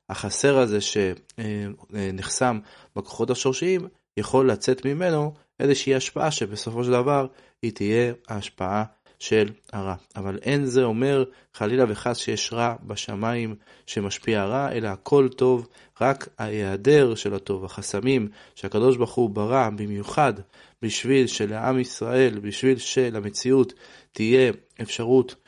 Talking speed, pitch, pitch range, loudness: 115 wpm, 120 Hz, 105-130 Hz, -24 LUFS